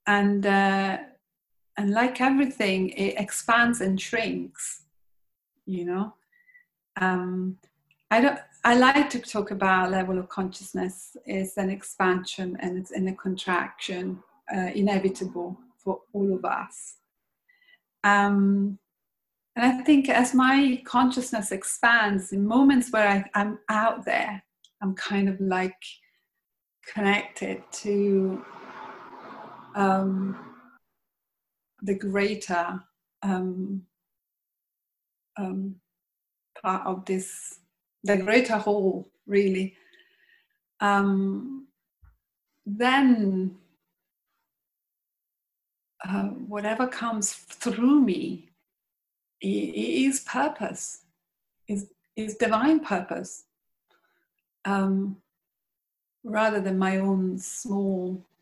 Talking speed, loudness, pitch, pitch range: 90 wpm, -25 LUFS, 200 Hz, 190-230 Hz